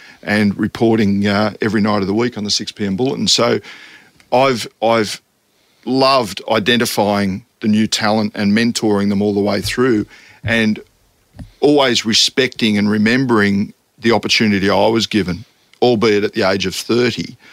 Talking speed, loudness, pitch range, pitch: 150 wpm, -15 LUFS, 100-115 Hz, 105 Hz